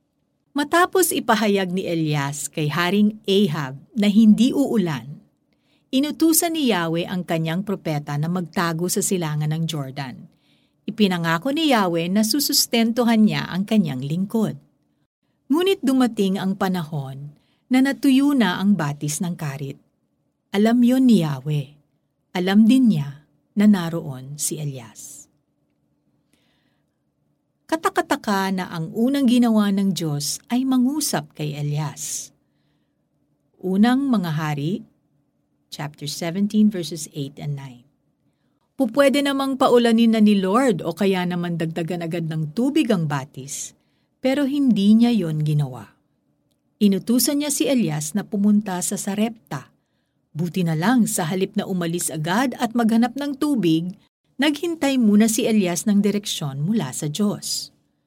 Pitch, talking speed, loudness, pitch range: 195 Hz, 125 wpm, -21 LUFS, 155-235 Hz